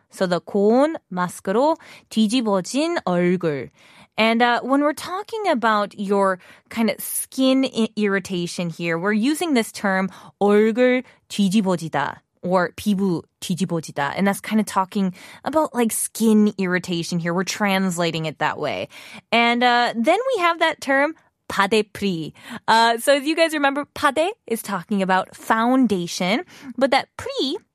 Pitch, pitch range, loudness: 215 Hz, 190-265 Hz, -21 LUFS